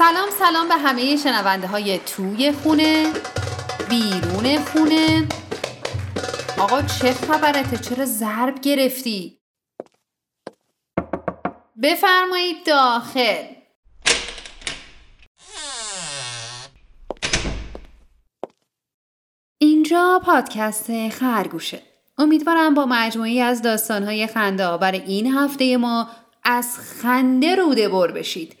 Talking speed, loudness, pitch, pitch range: 75 wpm, -19 LUFS, 250 Hz, 210-305 Hz